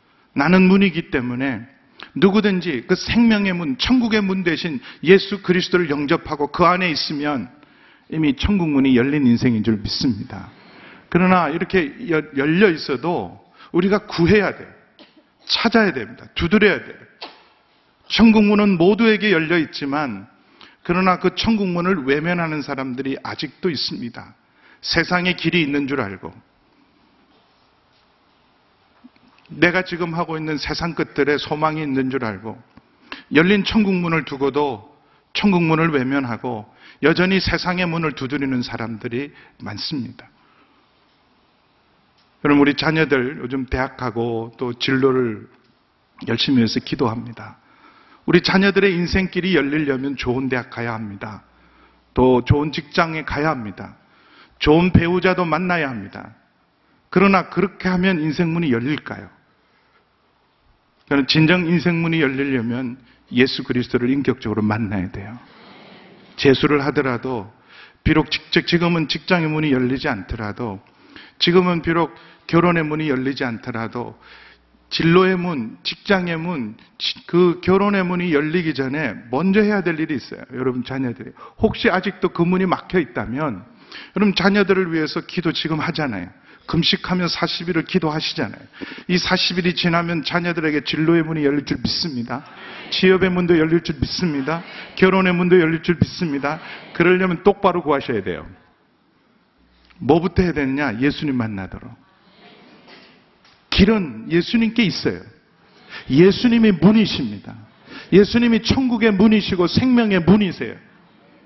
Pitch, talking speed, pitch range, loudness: 165 Hz, 295 characters per minute, 135-185 Hz, -19 LUFS